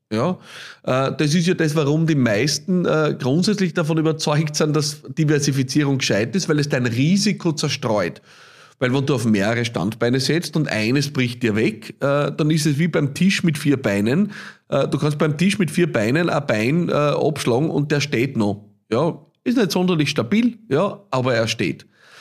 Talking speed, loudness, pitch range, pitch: 175 wpm, -20 LUFS, 130-170 Hz, 150 Hz